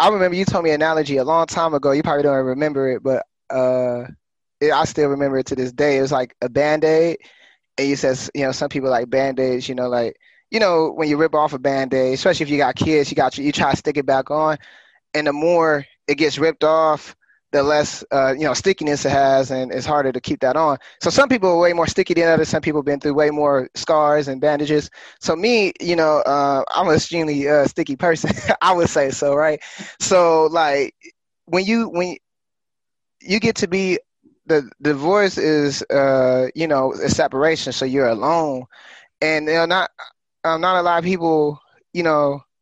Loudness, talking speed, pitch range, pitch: -18 LUFS, 215 wpm, 140-165 Hz, 150 Hz